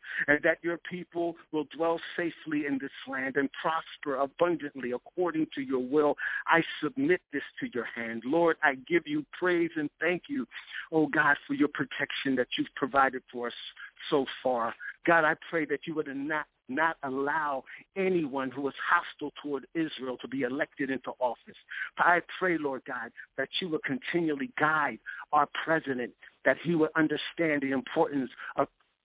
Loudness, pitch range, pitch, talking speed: -30 LUFS, 135-165 Hz, 150 Hz, 170 wpm